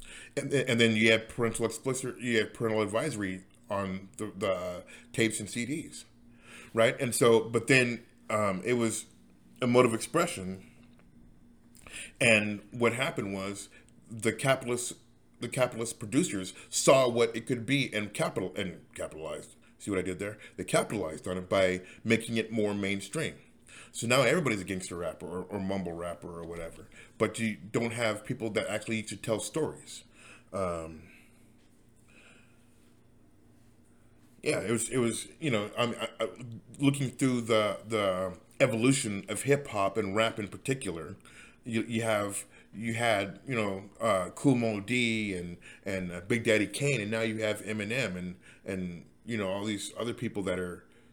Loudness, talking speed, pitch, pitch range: -30 LUFS, 160 wpm, 110 Hz, 100-120 Hz